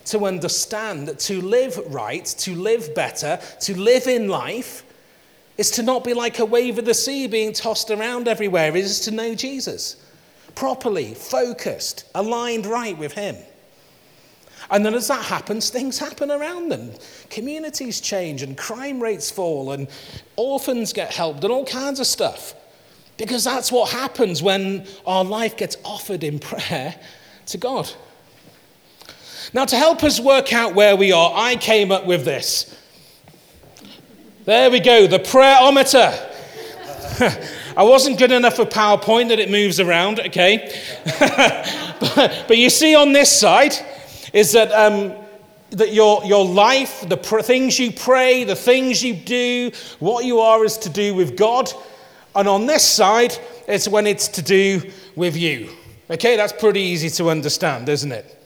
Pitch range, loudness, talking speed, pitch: 195-245 Hz, -17 LUFS, 160 wpm, 215 Hz